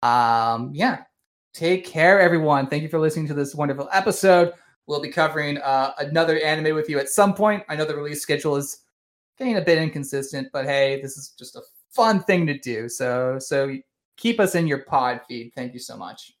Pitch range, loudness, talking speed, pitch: 135-170 Hz, -21 LUFS, 205 wpm, 145 Hz